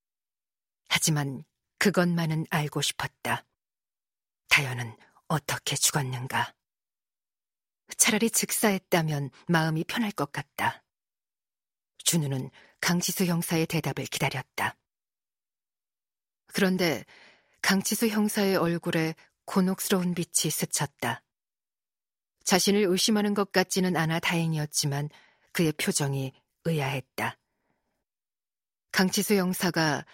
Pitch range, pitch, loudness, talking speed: 145-190 Hz, 170 Hz, -27 LUFS, 220 characters per minute